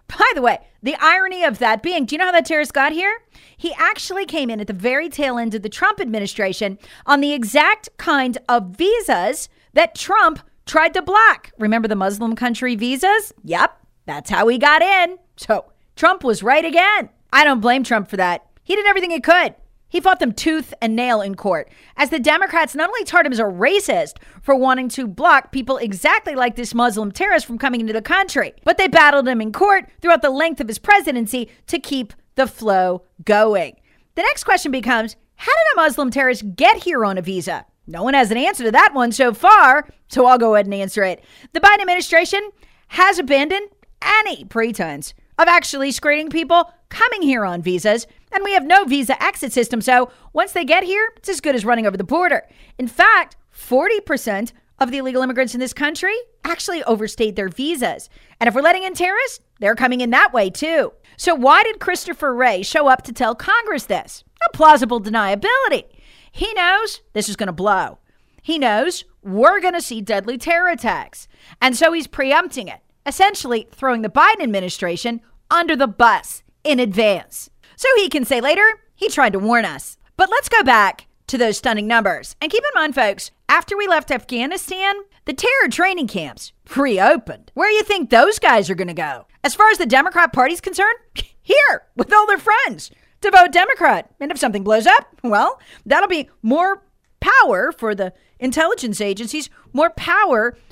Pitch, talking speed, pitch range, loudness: 280 Hz, 195 wpm, 230-355 Hz, -16 LUFS